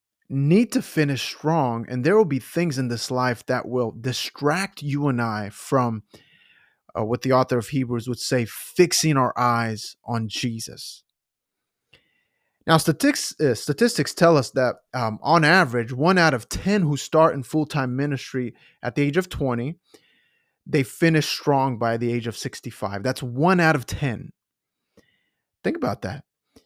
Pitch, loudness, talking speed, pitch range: 135 Hz, -22 LUFS, 160 wpm, 120-160 Hz